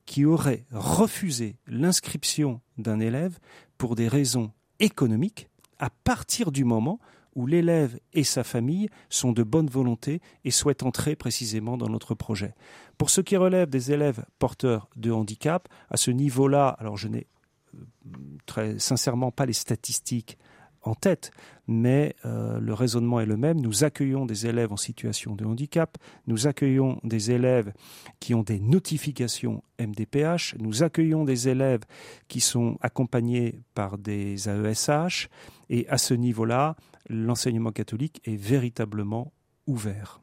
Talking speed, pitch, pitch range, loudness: 140 wpm, 125 Hz, 115-145 Hz, -26 LUFS